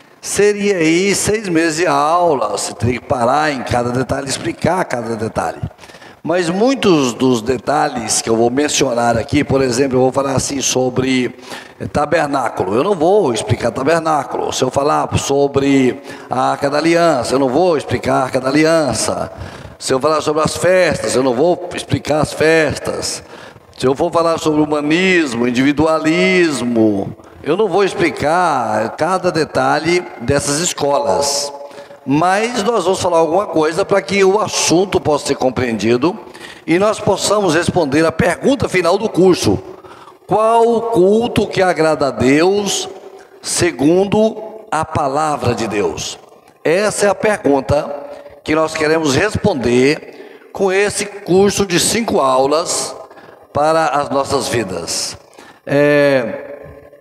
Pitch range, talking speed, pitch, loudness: 135-185 Hz, 140 wpm, 155 Hz, -15 LUFS